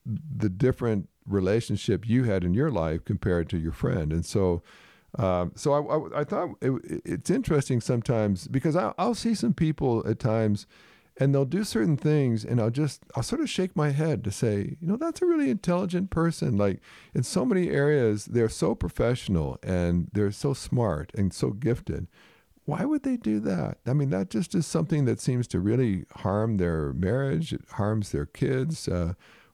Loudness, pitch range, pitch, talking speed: -27 LUFS, 100-155 Hz, 125 Hz, 195 wpm